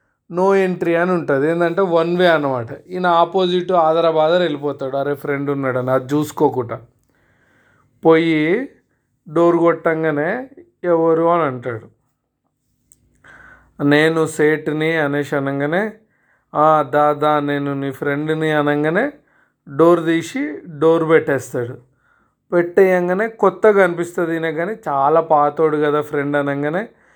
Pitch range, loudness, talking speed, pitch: 145-170 Hz, -17 LUFS, 105 wpm, 155 Hz